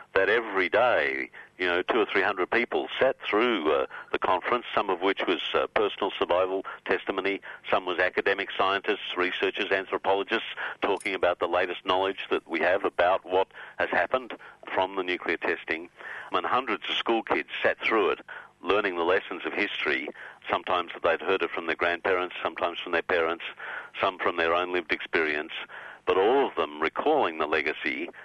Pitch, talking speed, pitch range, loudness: 95 Hz, 175 wpm, 90-95 Hz, -27 LUFS